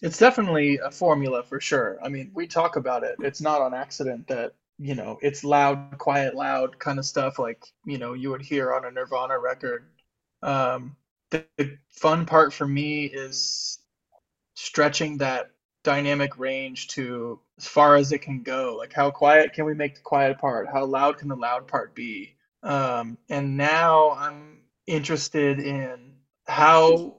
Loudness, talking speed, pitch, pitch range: -24 LUFS, 170 wpm, 140 Hz, 135-150 Hz